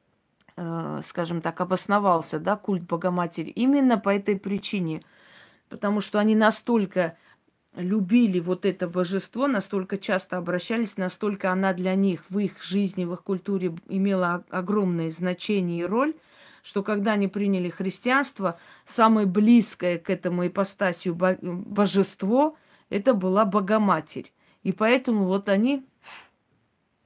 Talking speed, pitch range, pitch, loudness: 120 wpm, 180-210 Hz, 195 Hz, -25 LUFS